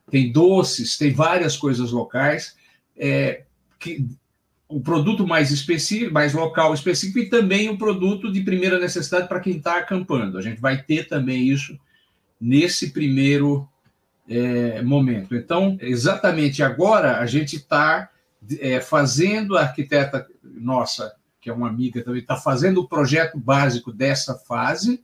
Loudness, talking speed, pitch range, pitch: -20 LUFS, 145 wpm, 130-175 Hz, 145 Hz